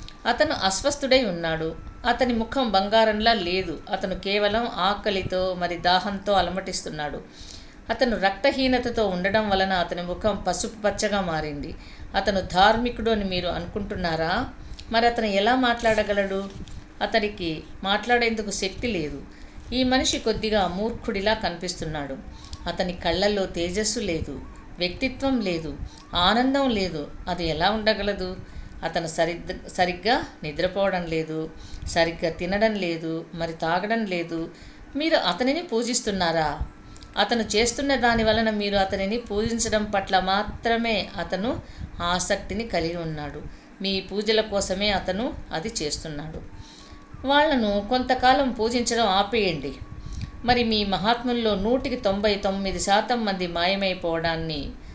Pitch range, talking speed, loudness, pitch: 180-230 Hz, 105 wpm, -24 LUFS, 200 Hz